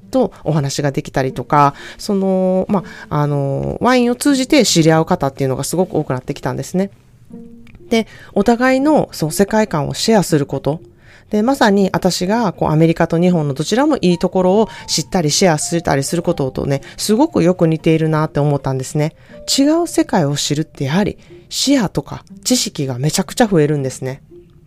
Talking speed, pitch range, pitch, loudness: 390 characters per minute, 145-200 Hz, 170 Hz, -16 LUFS